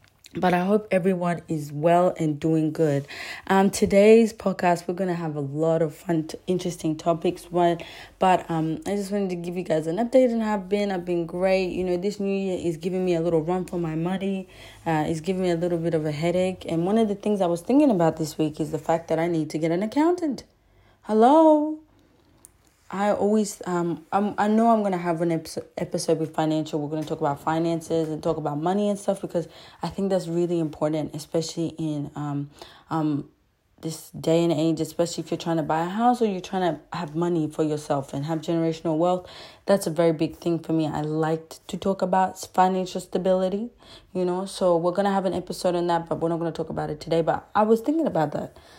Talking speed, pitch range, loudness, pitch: 230 wpm, 160-190 Hz, -24 LUFS, 170 Hz